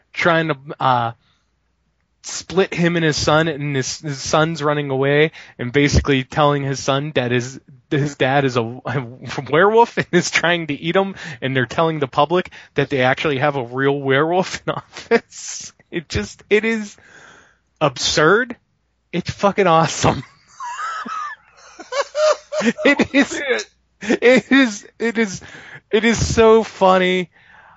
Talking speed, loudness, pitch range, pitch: 140 wpm, -18 LUFS, 140-200 Hz, 160 Hz